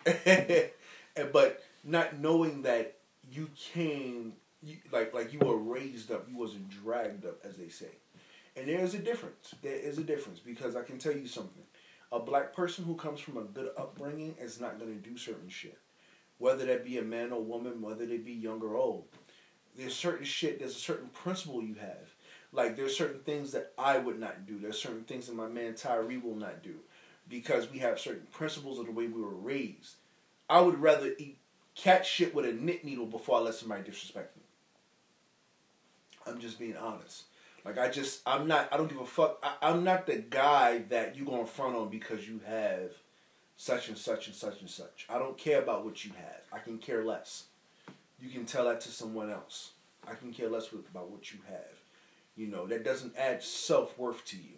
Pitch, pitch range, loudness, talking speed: 130 Hz, 115-160 Hz, -34 LUFS, 205 wpm